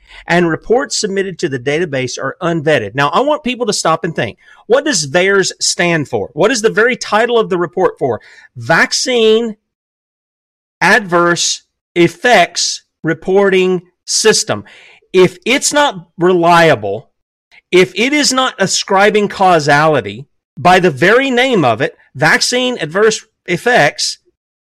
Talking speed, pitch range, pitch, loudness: 130 wpm, 170-235 Hz, 185 Hz, -12 LUFS